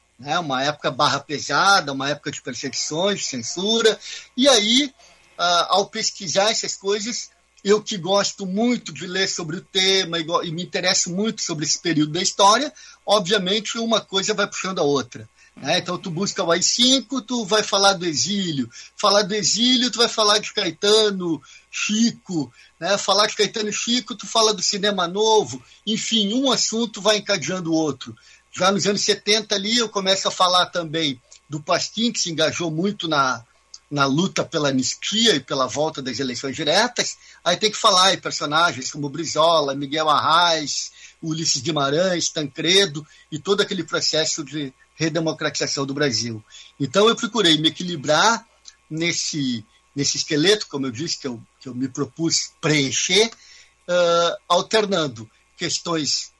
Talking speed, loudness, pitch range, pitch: 155 wpm, -20 LUFS, 155-210 Hz, 180 Hz